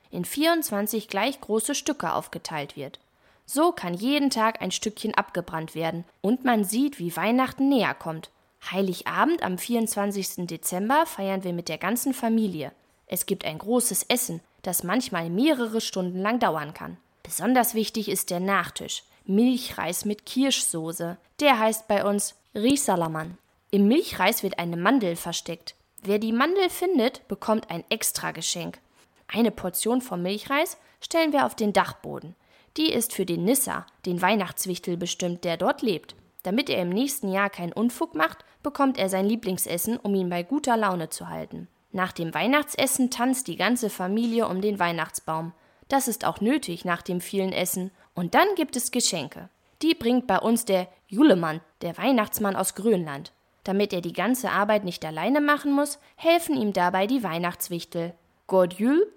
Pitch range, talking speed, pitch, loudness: 180-245 Hz, 160 wpm, 205 Hz, -25 LUFS